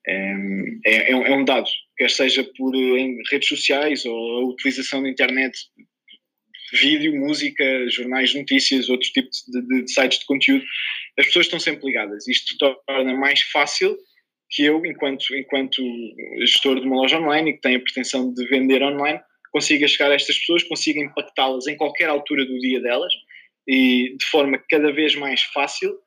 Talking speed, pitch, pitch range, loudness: 175 wpm, 135 Hz, 130-150 Hz, -19 LUFS